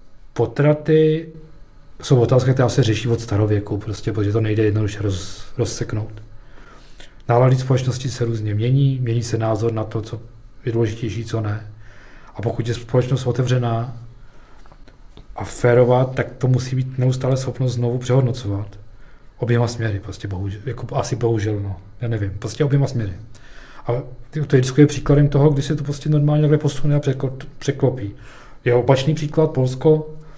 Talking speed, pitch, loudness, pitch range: 150 wpm, 120 Hz, -20 LUFS, 110-135 Hz